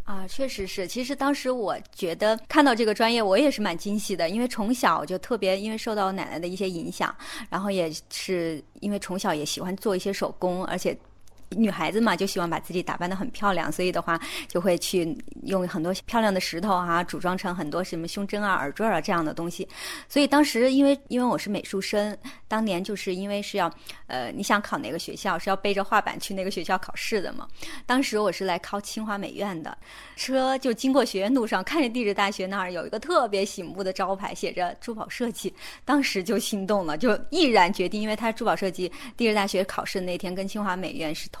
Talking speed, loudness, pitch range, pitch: 335 characters per minute, -26 LUFS, 185-230 Hz, 200 Hz